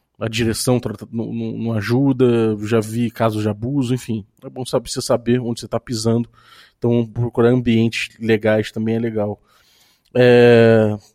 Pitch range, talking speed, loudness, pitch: 110-120 Hz, 140 wpm, -18 LUFS, 115 Hz